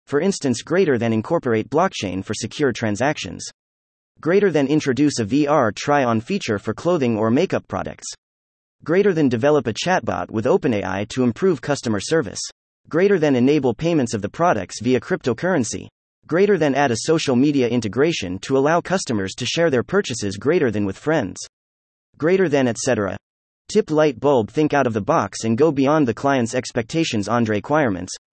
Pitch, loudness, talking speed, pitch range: 130 Hz, -20 LUFS, 165 wpm, 110-155 Hz